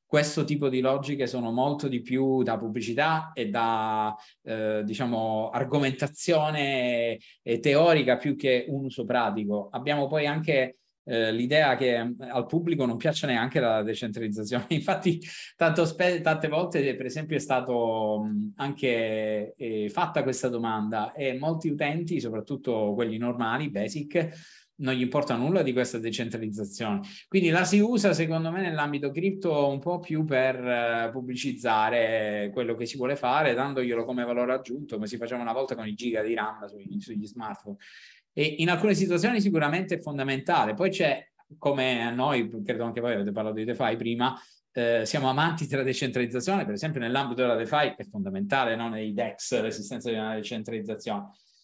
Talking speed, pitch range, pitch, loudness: 160 wpm, 115-150 Hz, 130 Hz, -27 LUFS